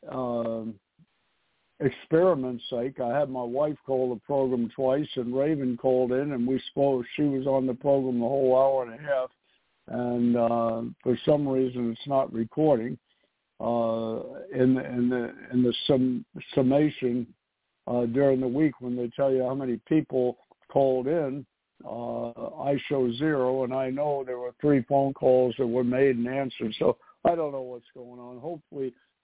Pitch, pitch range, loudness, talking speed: 130 Hz, 120-140 Hz, -27 LUFS, 175 wpm